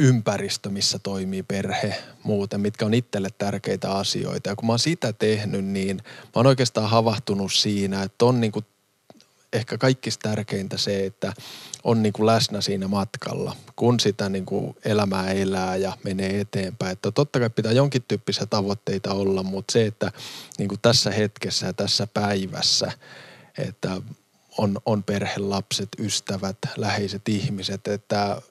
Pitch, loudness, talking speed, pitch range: 105 Hz, -24 LUFS, 145 wpm, 100-115 Hz